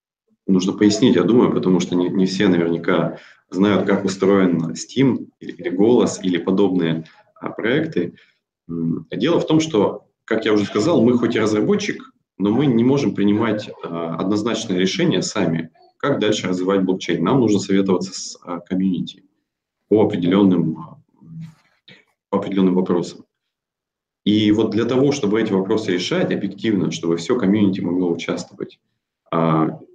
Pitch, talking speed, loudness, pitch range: 95 Hz, 145 wpm, -19 LUFS, 90-110 Hz